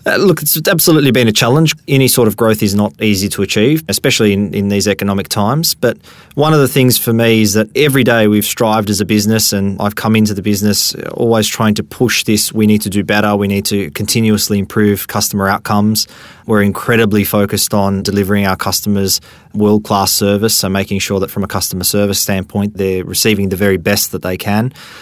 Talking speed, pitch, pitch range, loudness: 210 wpm, 105 Hz, 100-115 Hz, -12 LUFS